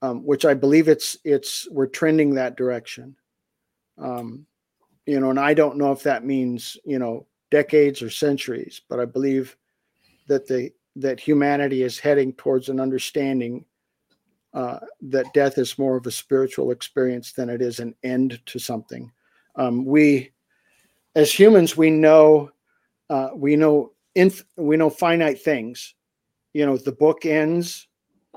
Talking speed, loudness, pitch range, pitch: 150 wpm, -20 LUFS, 130-150 Hz, 135 Hz